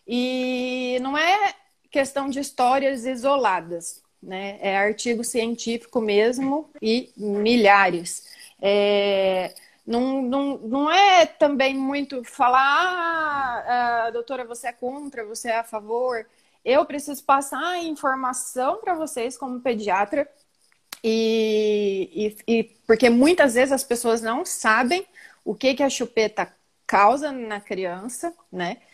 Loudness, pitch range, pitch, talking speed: -22 LUFS, 220-280 Hz, 250 Hz, 120 wpm